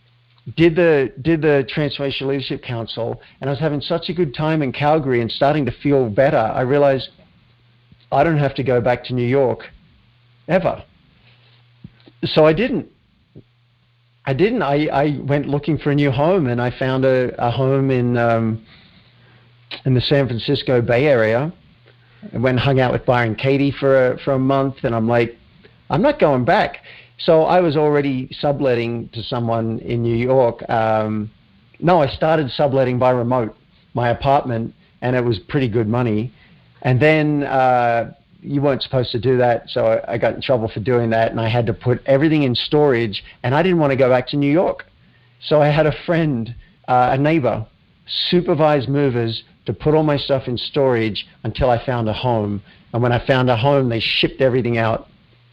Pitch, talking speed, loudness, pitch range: 130 Hz, 185 wpm, -18 LUFS, 120-145 Hz